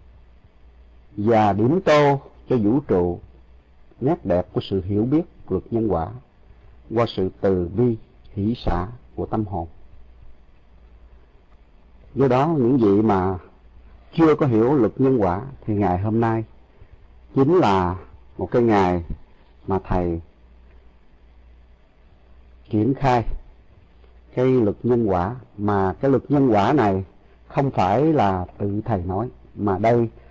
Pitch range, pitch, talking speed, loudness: 70-115 Hz, 95 Hz, 130 wpm, -21 LUFS